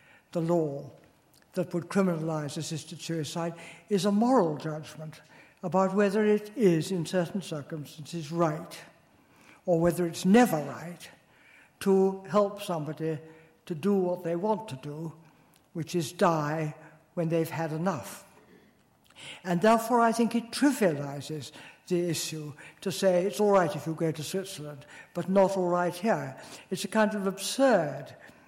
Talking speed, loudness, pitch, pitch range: 145 wpm, -28 LUFS, 170 Hz, 155-195 Hz